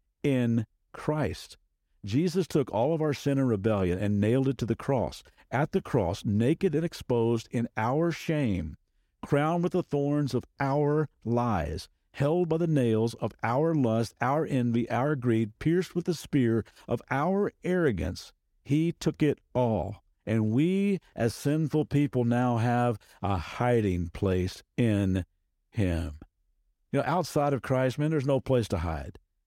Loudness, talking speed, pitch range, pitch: -28 LUFS, 155 wpm, 105-150 Hz, 125 Hz